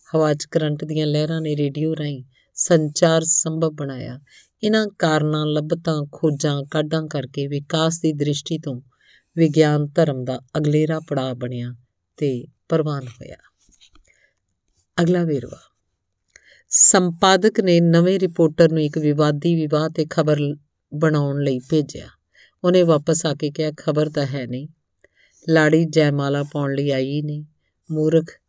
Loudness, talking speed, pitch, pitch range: -19 LUFS, 125 wpm, 150 Hz, 140-160 Hz